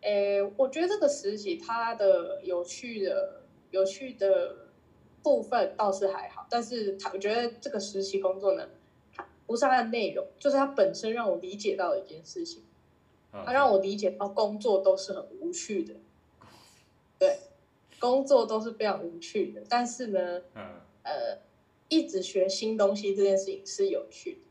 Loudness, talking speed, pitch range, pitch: -29 LUFS, 245 characters per minute, 195-280 Hz, 220 Hz